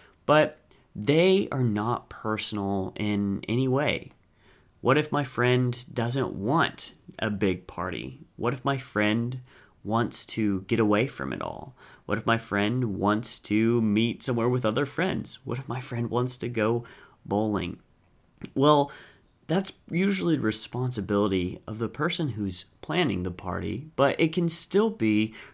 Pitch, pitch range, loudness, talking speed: 115 Hz, 105-135 Hz, -27 LUFS, 150 wpm